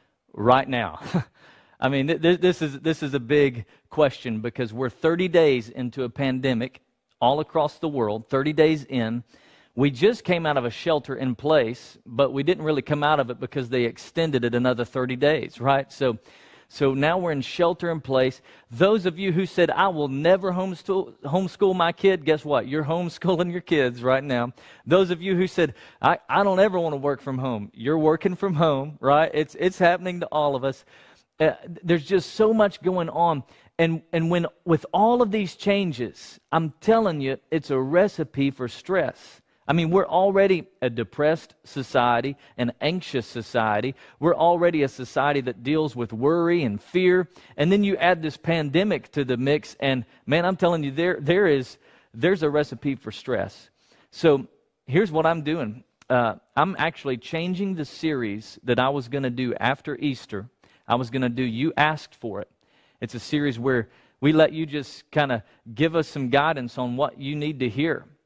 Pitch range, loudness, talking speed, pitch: 130-170 Hz, -23 LUFS, 190 wpm, 150 Hz